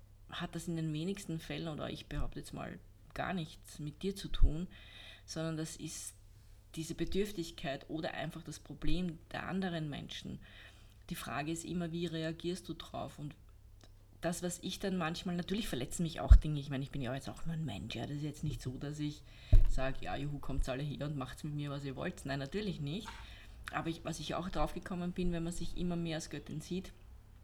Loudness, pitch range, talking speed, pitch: -39 LUFS, 130-170 Hz, 215 wpm, 155 Hz